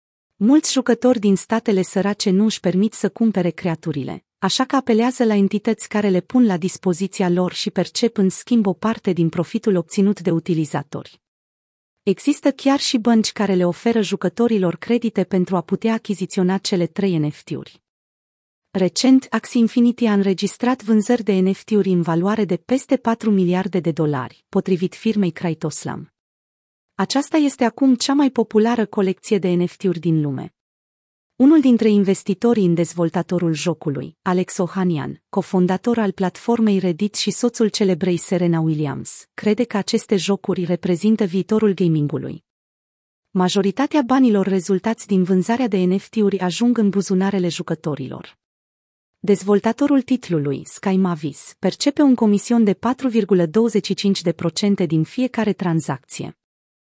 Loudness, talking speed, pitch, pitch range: -19 LUFS, 135 wpm, 195 Hz, 175-225 Hz